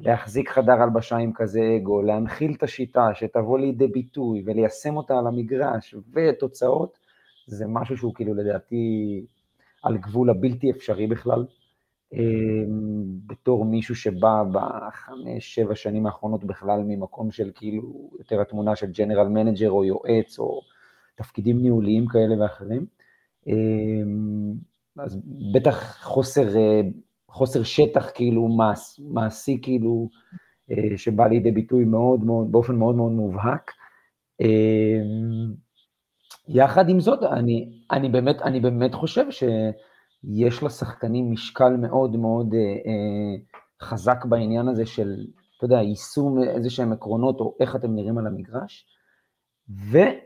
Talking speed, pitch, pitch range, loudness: 120 wpm, 115 Hz, 110-125 Hz, -23 LUFS